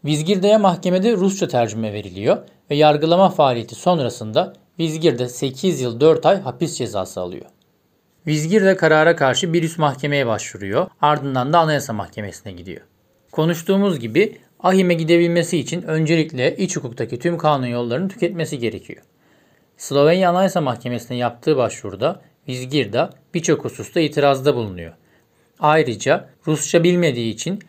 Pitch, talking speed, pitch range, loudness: 155 Hz, 120 wpm, 125-175 Hz, -18 LUFS